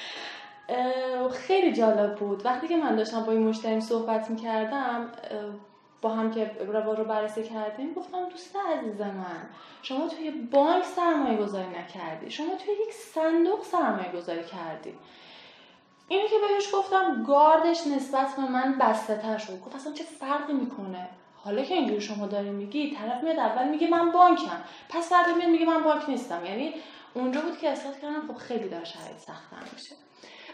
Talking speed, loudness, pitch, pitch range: 160 wpm, -27 LUFS, 260 Hz, 215-325 Hz